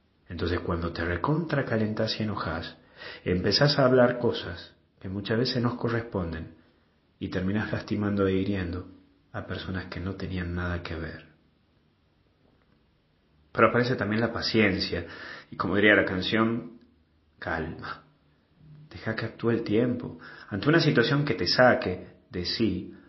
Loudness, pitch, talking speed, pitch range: -27 LUFS, 100 Hz, 135 wpm, 90-115 Hz